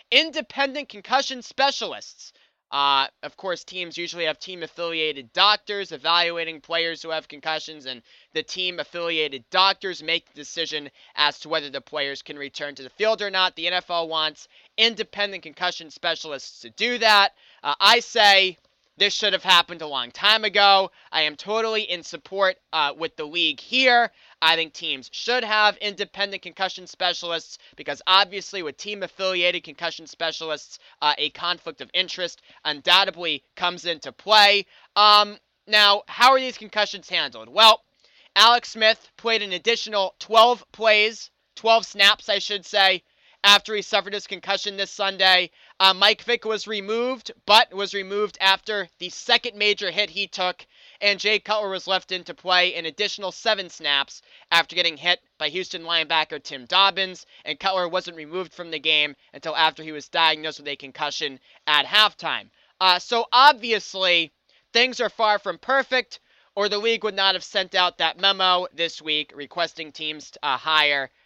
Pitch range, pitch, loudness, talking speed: 160-210 Hz, 185 Hz, -21 LUFS, 165 wpm